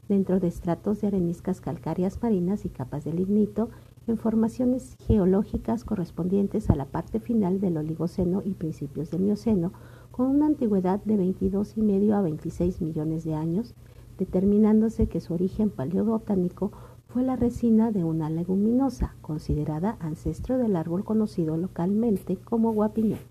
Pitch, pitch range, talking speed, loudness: 195 Hz, 170-220 Hz, 145 wpm, -26 LUFS